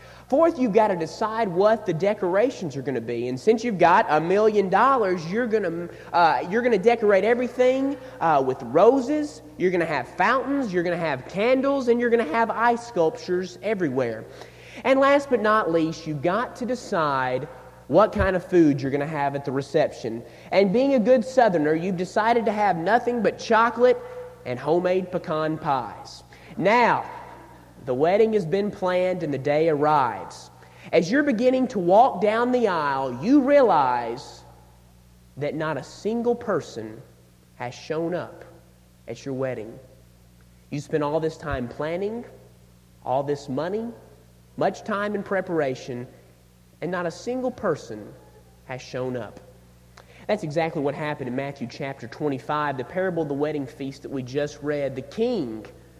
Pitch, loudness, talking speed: 165 Hz, -23 LUFS, 165 wpm